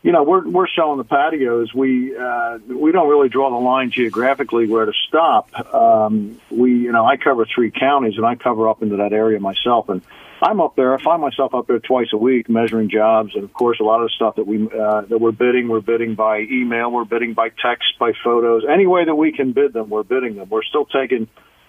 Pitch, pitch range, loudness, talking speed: 115 Hz, 110-130 Hz, -17 LUFS, 240 wpm